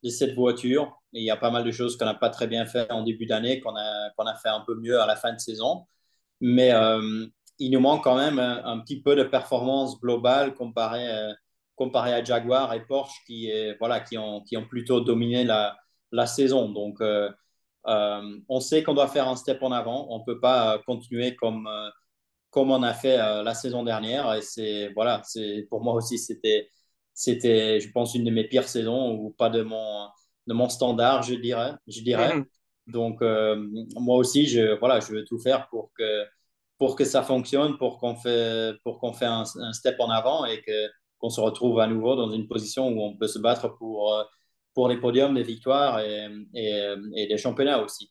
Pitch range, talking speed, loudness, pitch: 110-125 Hz, 210 wpm, -25 LUFS, 120 Hz